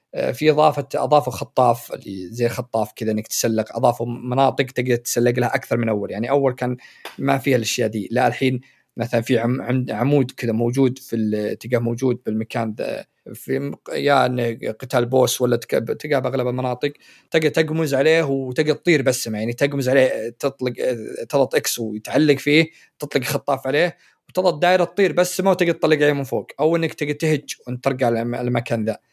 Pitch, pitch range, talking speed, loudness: 130 Hz, 120-145 Hz, 165 wpm, -20 LUFS